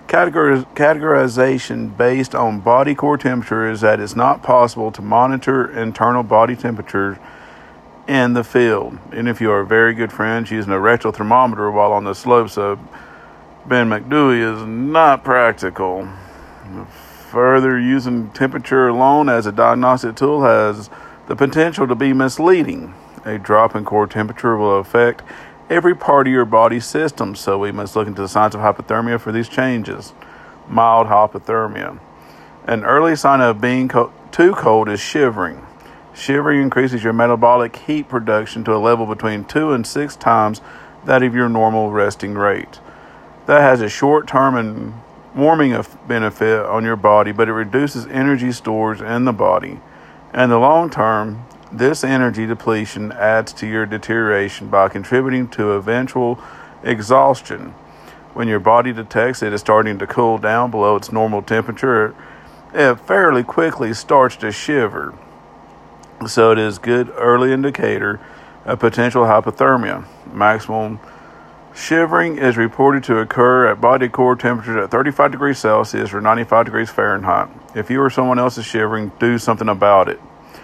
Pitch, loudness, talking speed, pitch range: 115 Hz, -15 LUFS, 155 wpm, 110-130 Hz